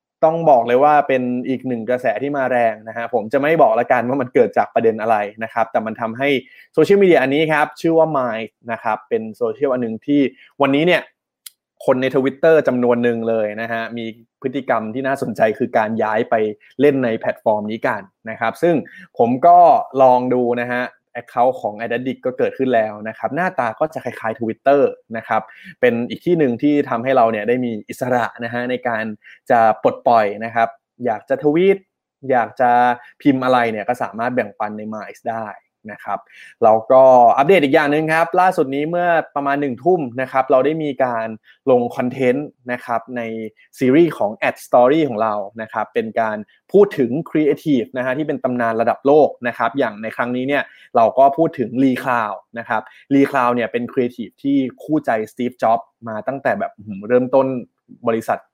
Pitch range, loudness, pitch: 115-140 Hz, -18 LUFS, 125 Hz